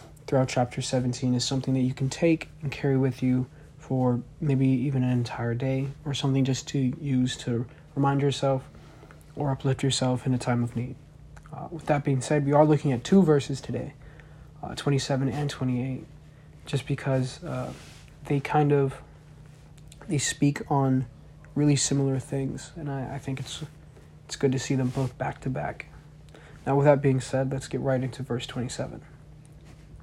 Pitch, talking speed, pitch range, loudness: 135 Hz, 175 wpm, 130-145 Hz, -27 LUFS